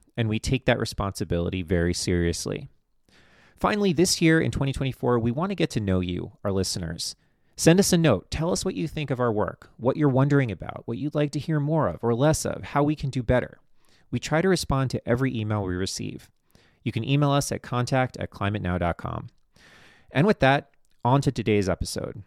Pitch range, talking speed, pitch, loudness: 105-145 Hz, 200 wpm, 125 Hz, -25 LUFS